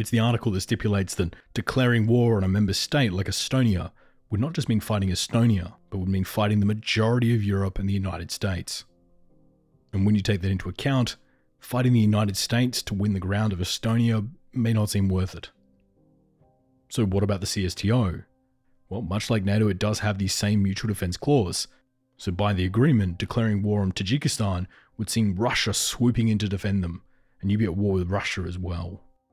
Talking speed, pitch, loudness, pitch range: 195 wpm, 105 Hz, -25 LUFS, 95-120 Hz